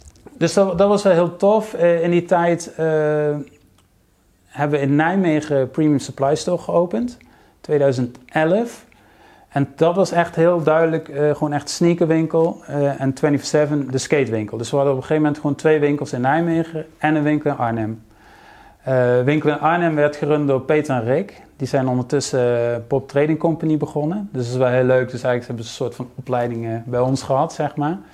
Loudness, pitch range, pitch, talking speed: -19 LUFS, 130-160 Hz, 145 Hz, 190 wpm